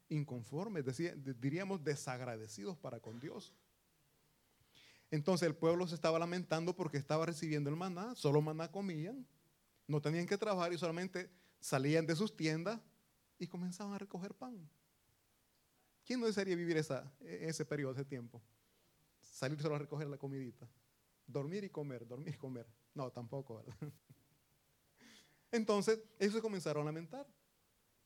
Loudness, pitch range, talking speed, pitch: -40 LUFS, 135-180 Hz, 140 wpm, 155 Hz